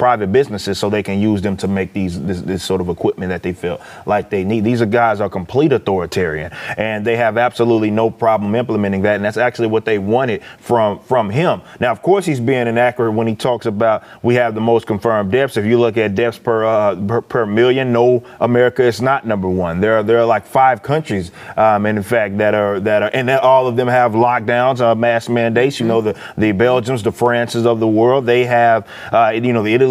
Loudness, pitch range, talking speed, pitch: -15 LUFS, 105-120 Hz, 235 wpm, 115 Hz